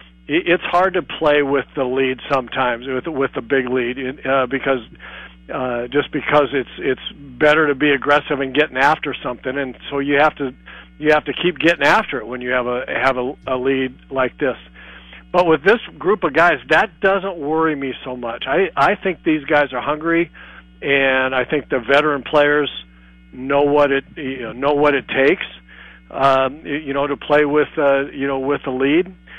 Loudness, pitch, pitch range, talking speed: -18 LUFS, 140 Hz, 130-150 Hz, 195 wpm